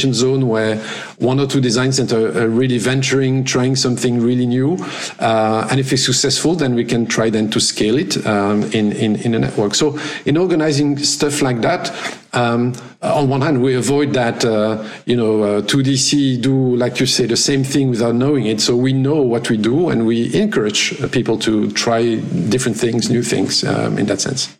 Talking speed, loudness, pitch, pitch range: 200 wpm, -16 LUFS, 125 Hz, 115-135 Hz